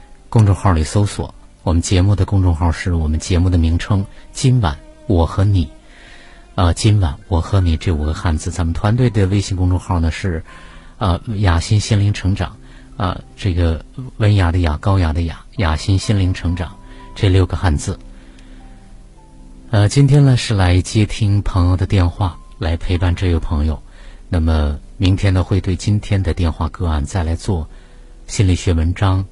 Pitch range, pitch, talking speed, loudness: 85-100 Hz, 90 Hz, 250 characters per minute, -17 LUFS